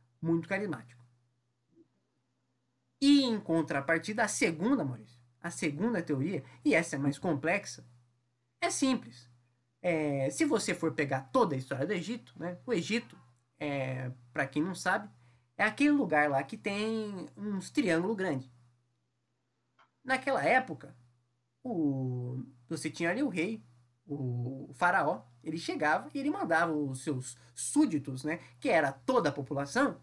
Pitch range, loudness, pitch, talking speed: 125-175 Hz, -32 LUFS, 145 Hz, 140 wpm